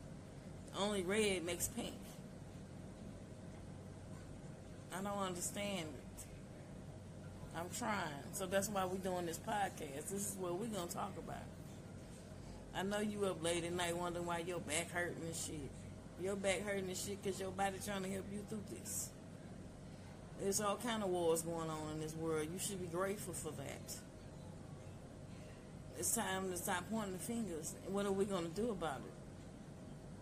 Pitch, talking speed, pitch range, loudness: 185 Hz, 165 wpm, 170-200 Hz, -42 LUFS